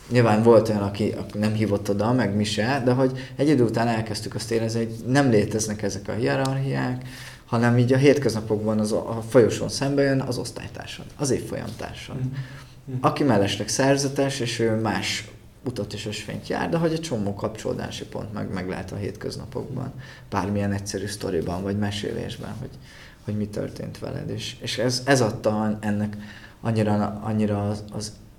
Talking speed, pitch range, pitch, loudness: 170 wpm, 105-130 Hz, 110 Hz, -24 LUFS